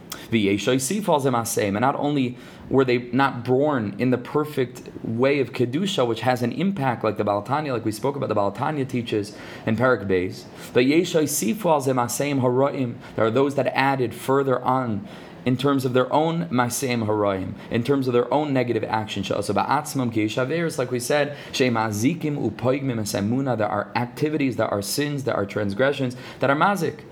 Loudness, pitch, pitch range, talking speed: -23 LUFS, 125 Hz, 115-140 Hz, 140 wpm